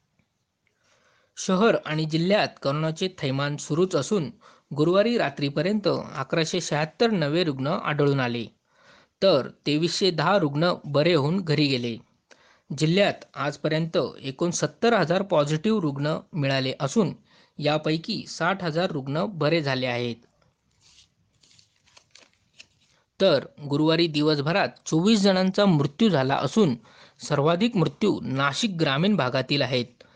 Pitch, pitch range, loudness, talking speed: 155 Hz, 140-185 Hz, -24 LUFS, 105 wpm